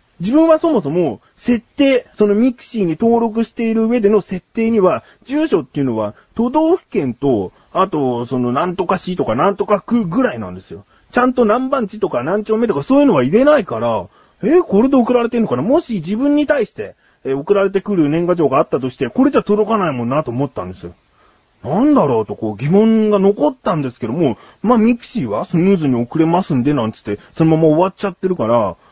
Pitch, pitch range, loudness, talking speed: 205 Hz, 155-240 Hz, -16 LUFS, 425 characters per minute